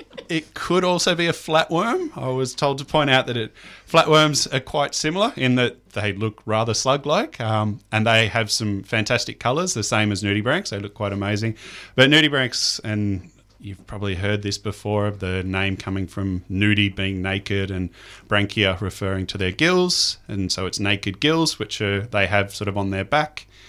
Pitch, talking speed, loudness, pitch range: 105 Hz, 190 wpm, -21 LUFS, 100-135 Hz